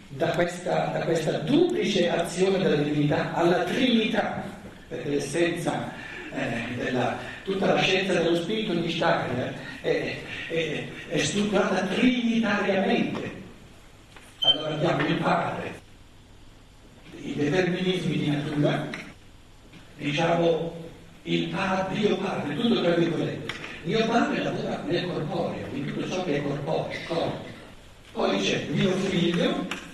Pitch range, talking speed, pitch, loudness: 150-190 Hz, 120 wpm, 170 Hz, -26 LUFS